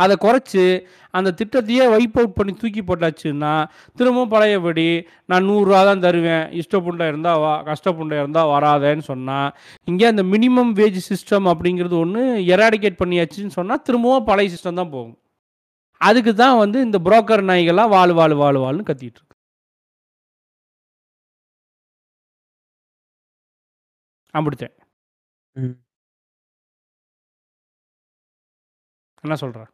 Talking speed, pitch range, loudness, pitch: 100 wpm, 150-210 Hz, -17 LUFS, 180 Hz